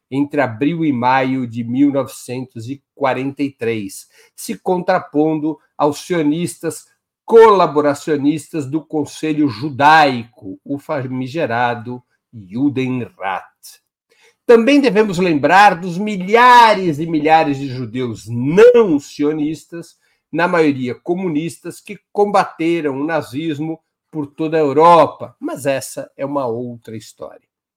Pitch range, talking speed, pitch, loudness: 135-170 Hz, 95 wpm, 150 Hz, -15 LUFS